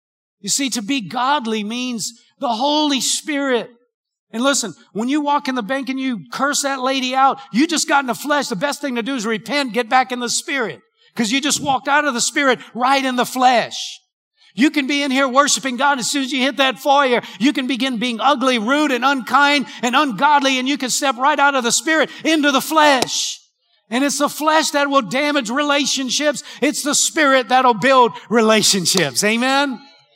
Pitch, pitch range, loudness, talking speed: 270 Hz, 245-285 Hz, -17 LUFS, 205 wpm